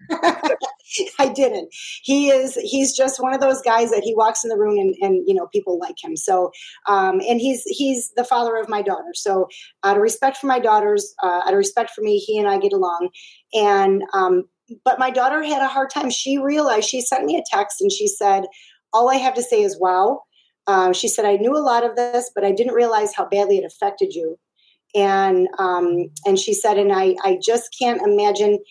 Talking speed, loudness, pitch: 220 wpm, -19 LUFS, 255 Hz